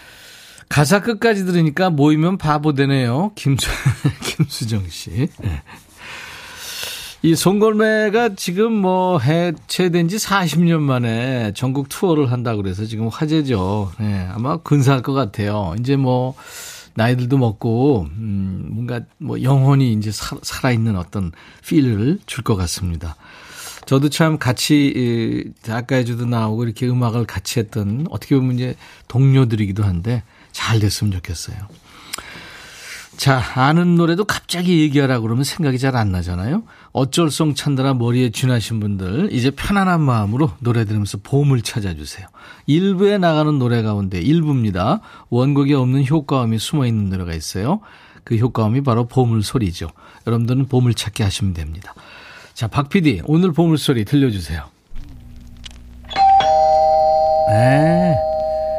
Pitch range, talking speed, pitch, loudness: 110-155 Hz, 290 characters per minute, 130 Hz, -18 LUFS